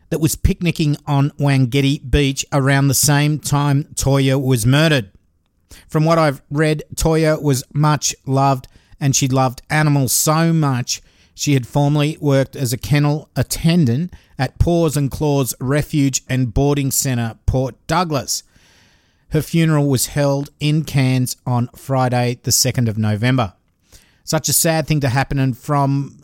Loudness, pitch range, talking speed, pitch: -17 LUFS, 125-150 Hz, 150 wpm, 140 Hz